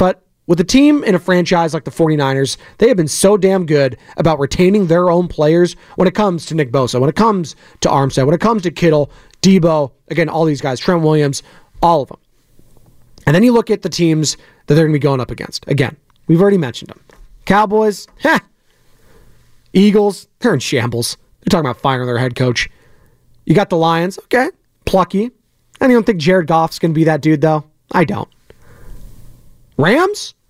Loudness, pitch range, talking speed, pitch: -14 LUFS, 145-190 Hz, 195 wpm, 165 Hz